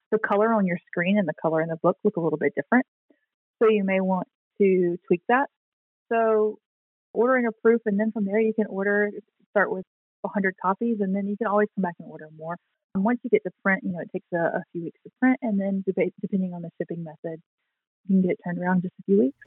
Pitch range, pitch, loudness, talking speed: 180-215 Hz, 195 Hz, -25 LUFS, 255 wpm